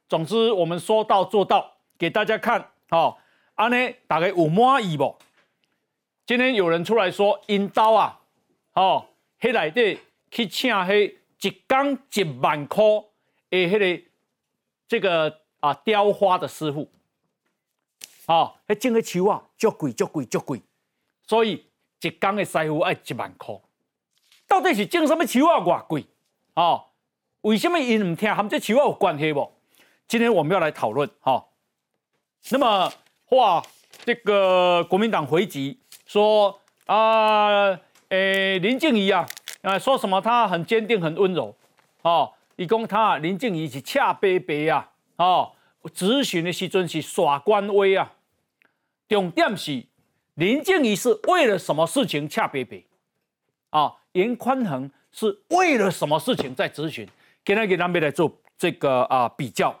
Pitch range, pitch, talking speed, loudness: 175-230 Hz, 205 Hz, 210 characters per minute, -22 LUFS